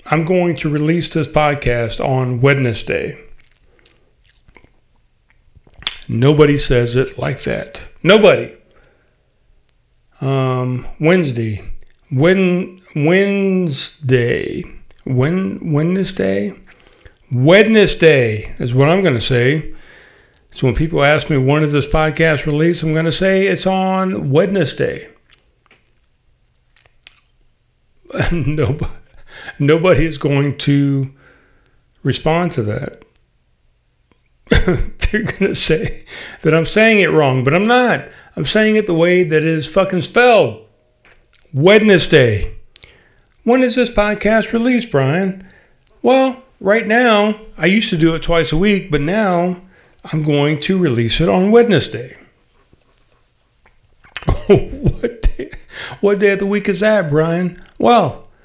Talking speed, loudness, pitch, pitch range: 115 wpm, -14 LUFS, 160 Hz, 135-190 Hz